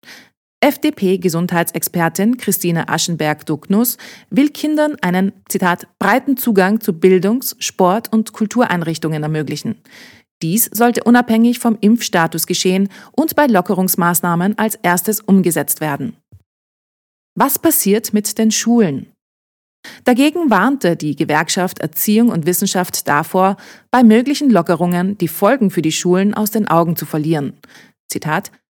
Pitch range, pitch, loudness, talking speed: 170-225 Hz, 195 Hz, -15 LUFS, 115 wpm